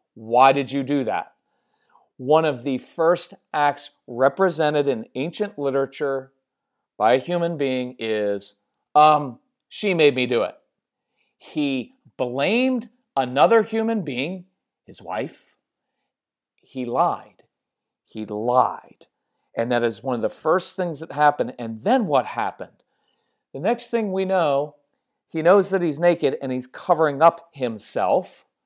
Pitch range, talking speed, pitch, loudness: 130-175 Hz, 135 wpm, 145 Hz, -22 LUFS